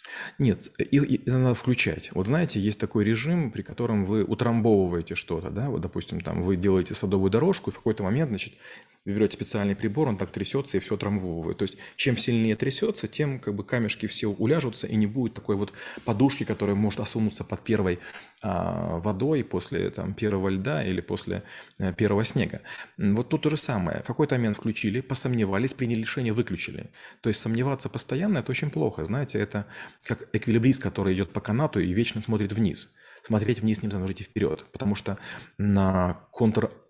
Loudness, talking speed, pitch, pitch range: -27 LUFS, 180 wpm, 110 Hz, 100-125 Hz